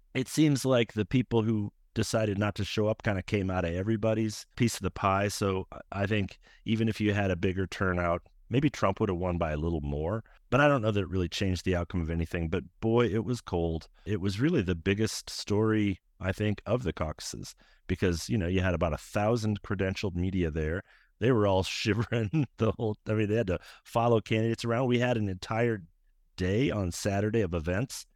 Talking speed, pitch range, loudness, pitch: 215 wpm, 90-110 Hz, -30 LUFS, 105 Hz